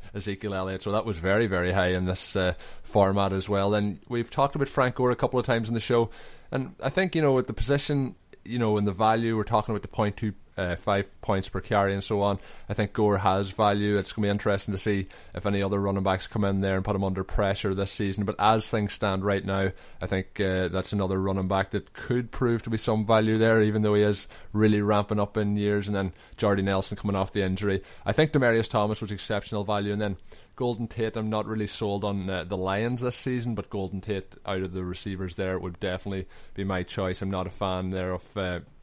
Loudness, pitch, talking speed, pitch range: -27 LUFS, 100 Hz, 250 wpm, 95-110 Hz